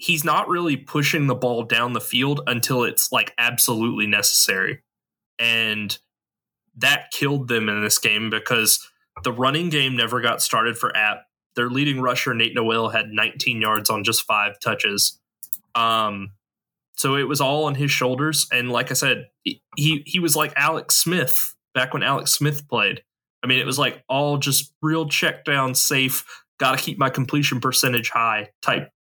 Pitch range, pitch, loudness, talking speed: 115-145 Hz, 130 Hz, -20 LUFS, 170 wpm